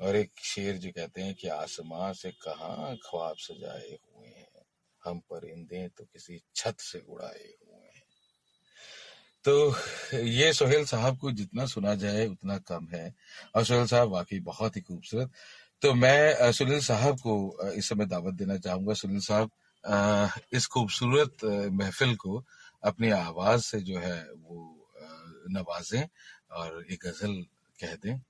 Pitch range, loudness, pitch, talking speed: 95-120 Hz, -29 LUFS, 105 Hz, 145 wpm